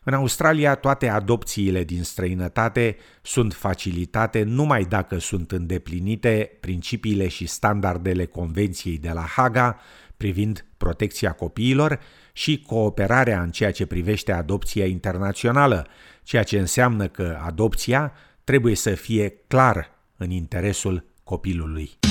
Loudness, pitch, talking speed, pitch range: -23 LUFS, 100 Hz, 115 wpm, 90-120 Hz